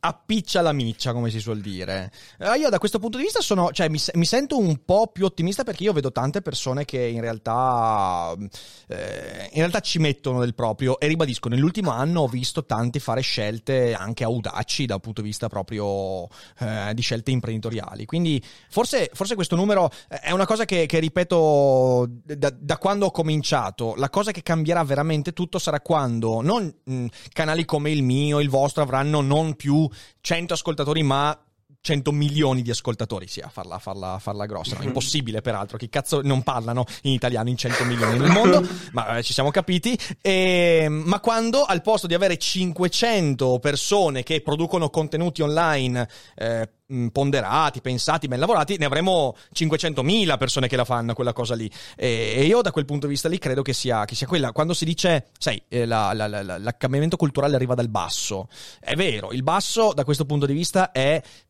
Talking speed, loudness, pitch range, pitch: 180 wpm, -23 LUFS, 120-165 Hz, 140 Hz